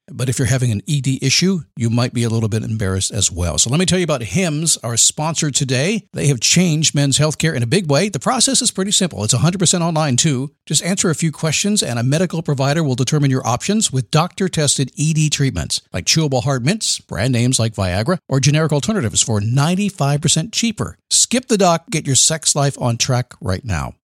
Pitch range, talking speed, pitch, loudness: 125-170 Hz, 215 wpm, 145 Hz, -16 LUFS